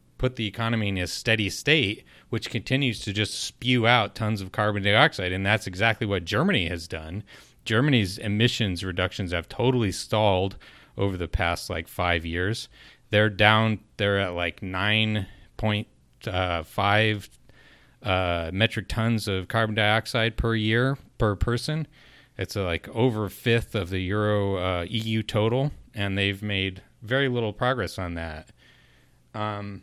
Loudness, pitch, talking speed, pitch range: -25 LUFS, 105 Hz, 155 wpm, 95-115 Hz